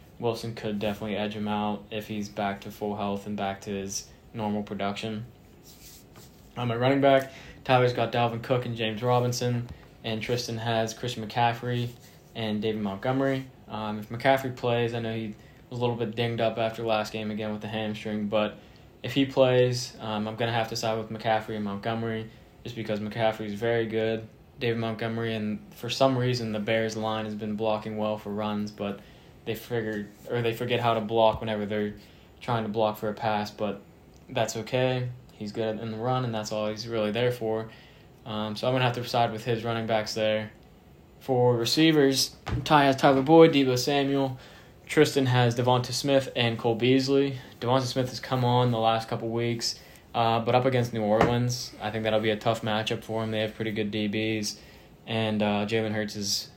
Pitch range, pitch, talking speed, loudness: 110-125 Hz, 115 Hz, 195 wpm, -27 LUFS